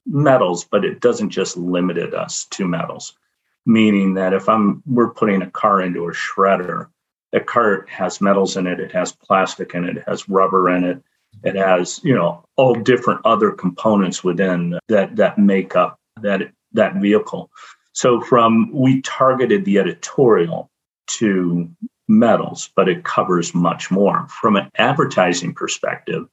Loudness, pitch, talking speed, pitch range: -17 LUFS, 95 Hz, 155 wpm, 90-110 Hz